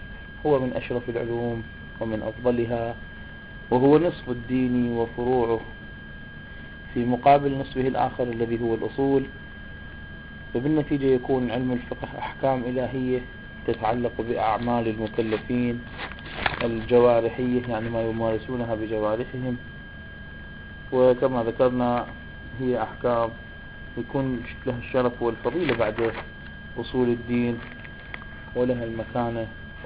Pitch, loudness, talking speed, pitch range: 120 Hz, -25 LUFS, 90 wpm, 110-125 Hz